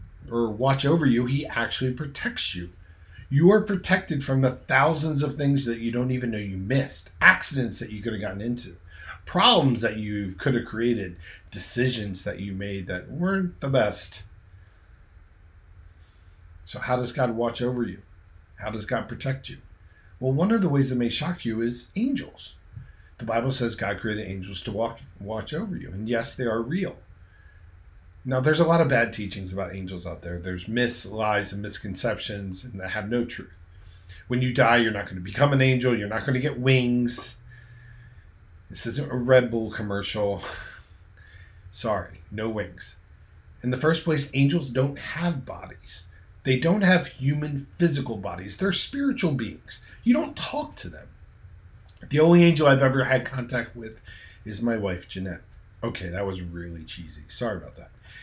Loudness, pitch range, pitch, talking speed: -25 LUFS, 95-130 Hz, 110 Hz, 175 wpm